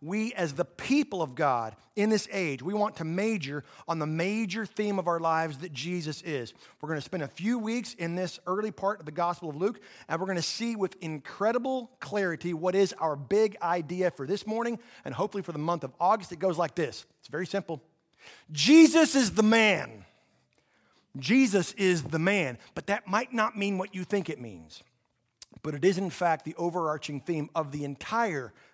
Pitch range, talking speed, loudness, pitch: 160-210 Hz, 200 wpm, -29 LUFS, 180 Hz